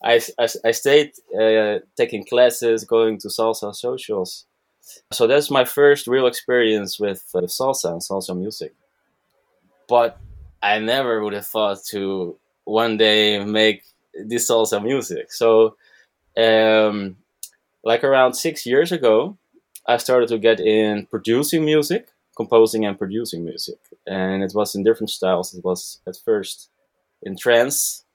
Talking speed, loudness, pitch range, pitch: 135 wpm, -19 LUFS, 105-125 Hz, 110 Hz